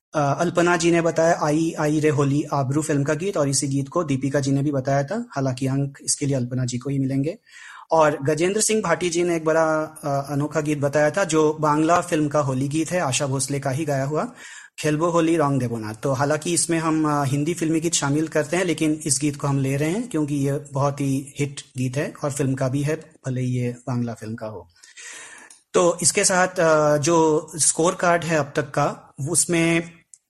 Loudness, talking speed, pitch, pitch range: -22 LUFS, 215 wpm, 150 Hz, 140-165 Hz